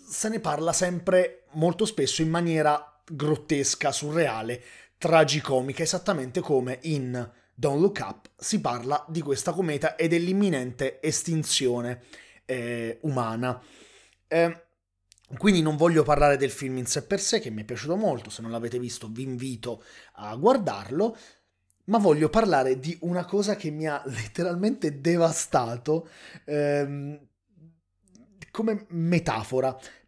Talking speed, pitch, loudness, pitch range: 130 wpm, 150 Hz, -26 LUFS, 130-170 Hz